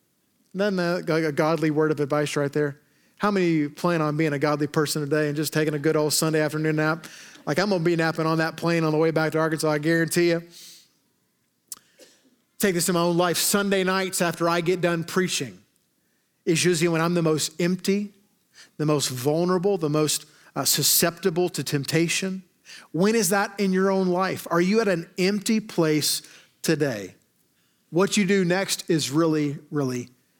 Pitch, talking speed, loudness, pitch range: 165 Hz, 190 wpm, -23 LUFS, 155-185 Hz